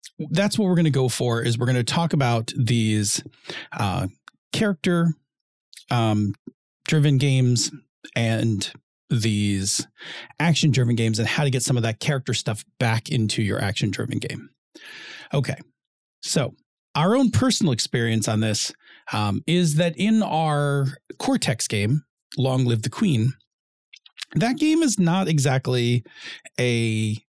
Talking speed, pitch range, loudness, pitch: 140 wpm, 115-165 Hz, -22 LUFS, 130 Hz